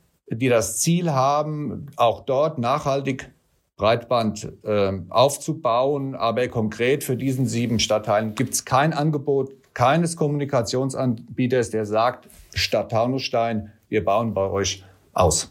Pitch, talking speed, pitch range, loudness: 125 Hz, 120 wpm, 110-140 Hz, -22 LUFS